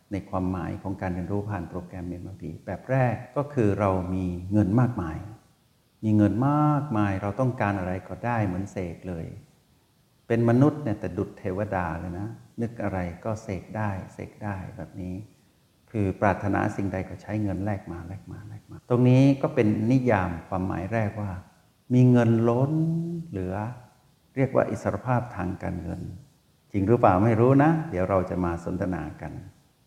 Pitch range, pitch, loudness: 95-120 Hz, 105 Hz, -26 LUFS